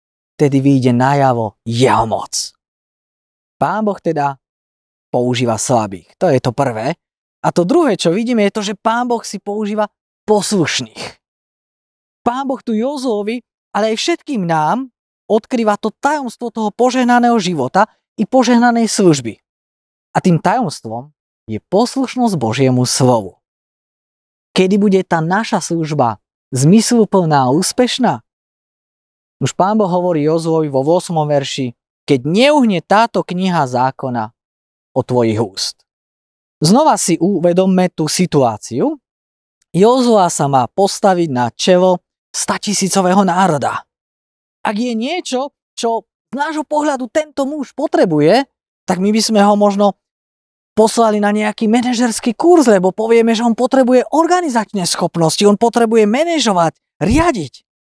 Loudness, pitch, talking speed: -14 LUFS, 190 Hz, 125 wpm